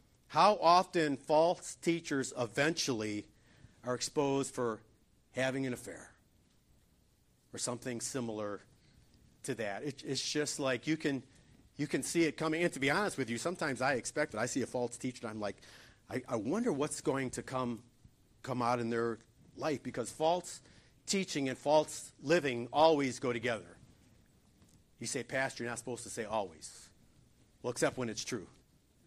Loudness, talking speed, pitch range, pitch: -35 LUFS, 165 wpm, 120-150 Hz, 130 Hz